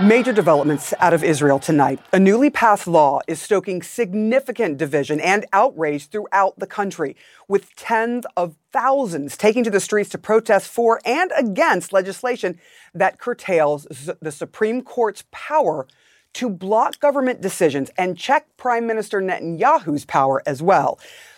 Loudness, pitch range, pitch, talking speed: -19 LUFS, 165-235 Hz, 200 Hz, 145 wpm